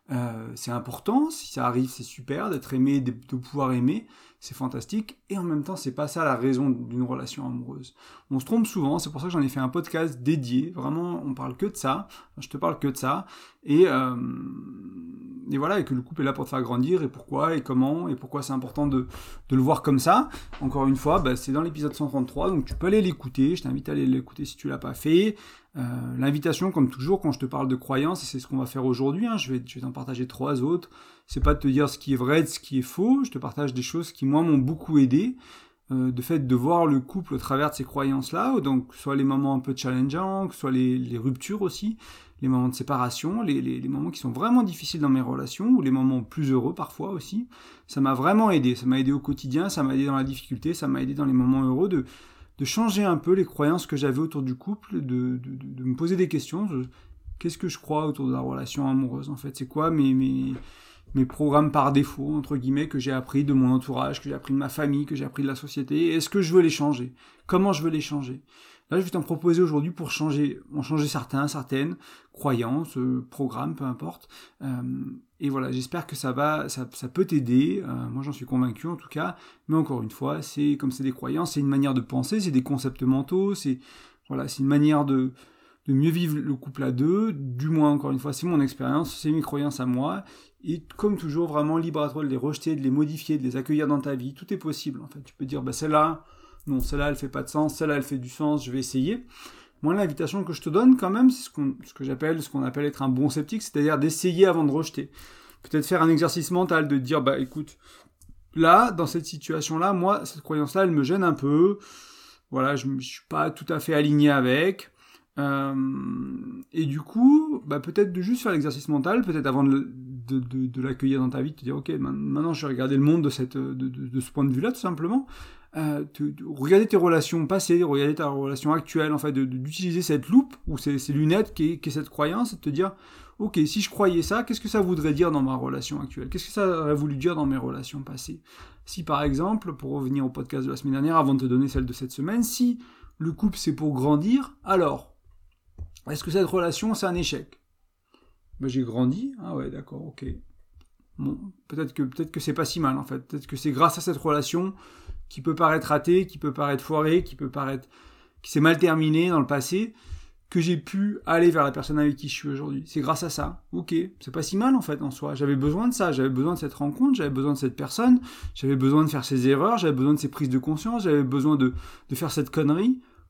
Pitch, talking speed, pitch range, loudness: 145 Hz, 245 wpm, 135-170 Hz, -25 LUFS